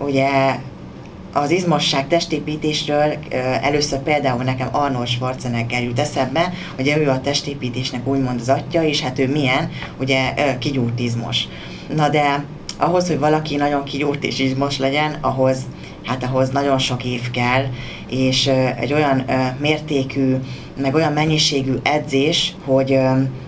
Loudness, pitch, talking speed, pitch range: -19 LUFS, 135 Hz, 130 wpm, 130-150 Hz